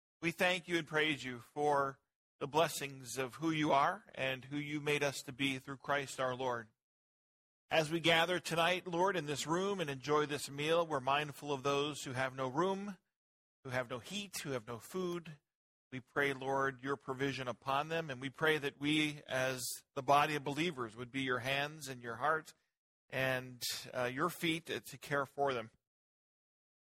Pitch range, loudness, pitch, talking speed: 130-160 Hz, -36 LUFS, 140 Hz, 190 wpm